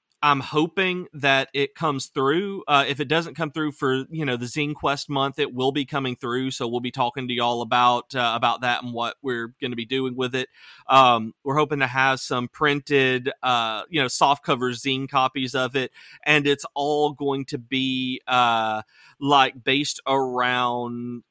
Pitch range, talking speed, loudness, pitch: 125-145 Hz, 195 wpm, -23 LUFS, 135 Hz